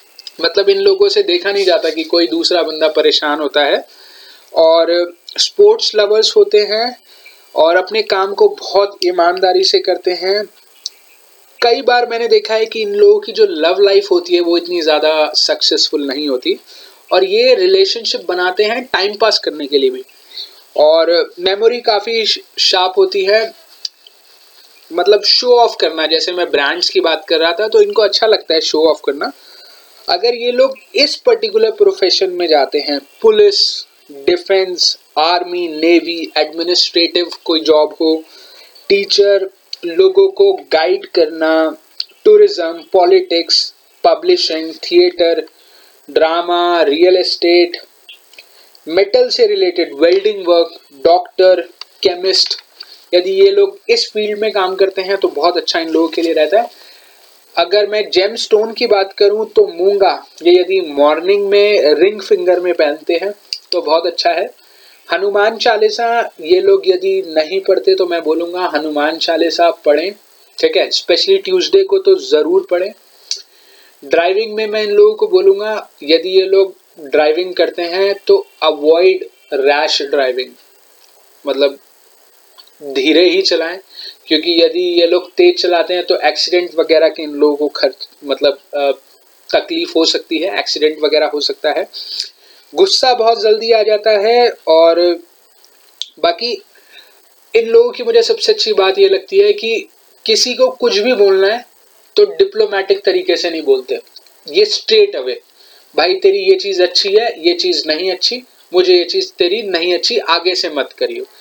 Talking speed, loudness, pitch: 155 wpm, -13 LUFS, 210 Hz